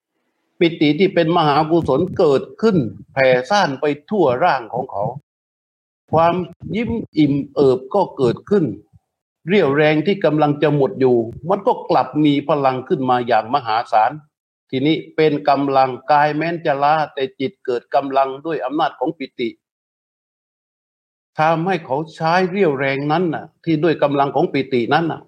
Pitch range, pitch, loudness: 135-170 Hz, 150 Hz, -18 LUFS